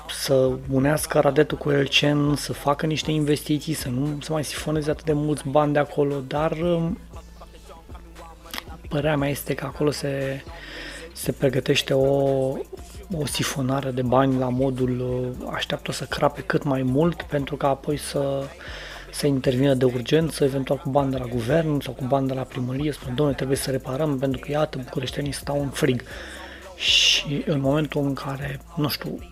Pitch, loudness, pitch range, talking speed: 140 Hz, -23 LUFS, 135-150 Hz, 165 wpm